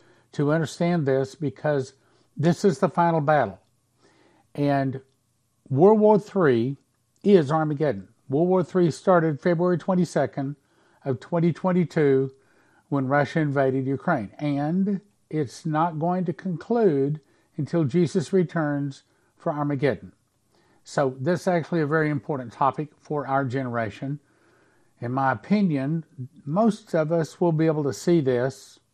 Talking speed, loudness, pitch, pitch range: 125 wpm, -24 LUFS, 150 Hz, 135-175 Hz